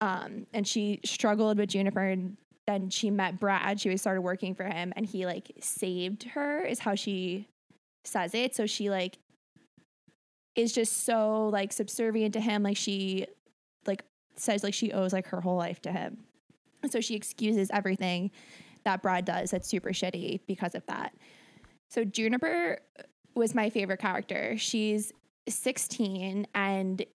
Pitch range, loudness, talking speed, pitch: 190-220 Hz, -31 LUFS, 155 wpm, 205 Hz